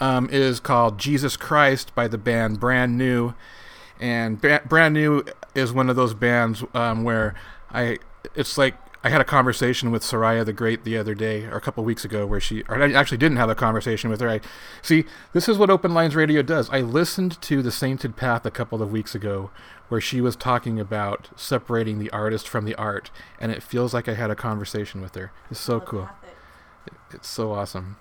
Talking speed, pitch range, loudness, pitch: 215 wpm, 110-135 Hz, -22 LUFS, 120 Hz